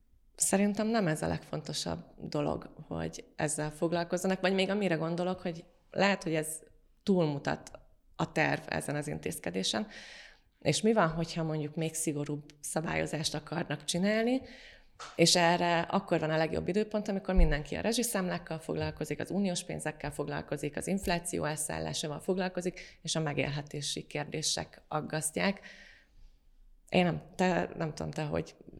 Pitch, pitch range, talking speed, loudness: 165 Hz, 150-185 Hz, 135 wpm, -32 LUFS